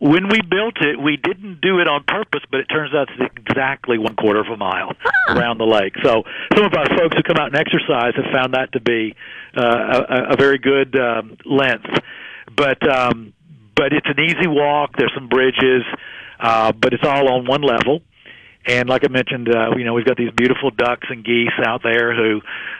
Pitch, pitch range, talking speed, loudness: 130 Hz, 120-145 Hz, 225 wpm, -17 LUFS